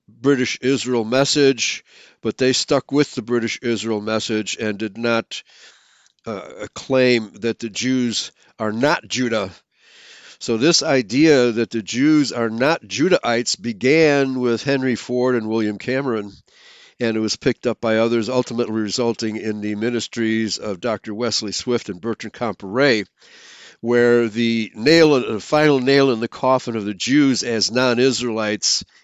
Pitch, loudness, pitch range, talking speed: 120 Hz, -19 LUFS, 110-130 Hz, 145 wpm